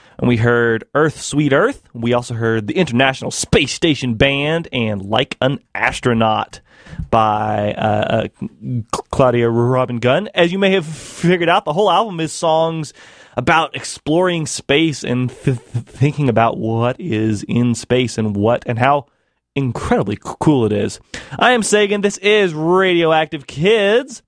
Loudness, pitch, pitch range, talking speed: -16 LUFS, 135 Hz, 120-160 Hz, 155 wpm